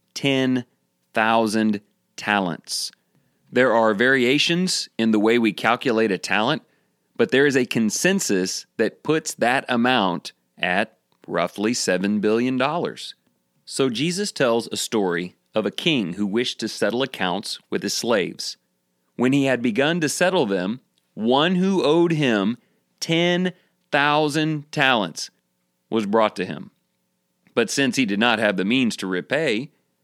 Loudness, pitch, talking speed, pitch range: -21 LUFS, 120 Hz, 135 wpm, 100-150 Hz